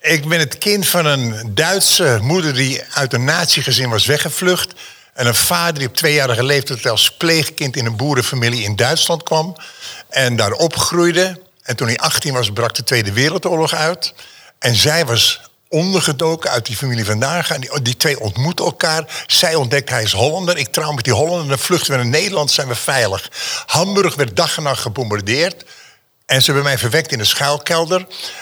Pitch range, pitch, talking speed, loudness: 125-165 Hz, 145 Hz, 190 wpm, -15 LUFS